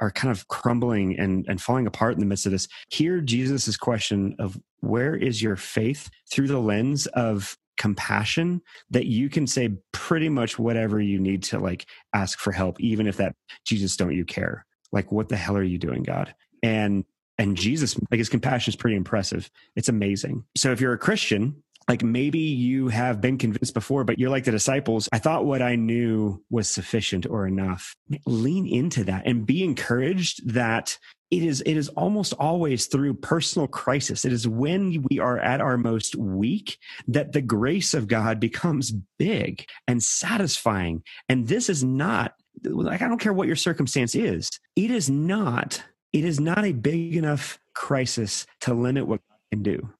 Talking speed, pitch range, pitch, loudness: 185 wpm, 105-140 Hz, 120 Hz, -25 LUFS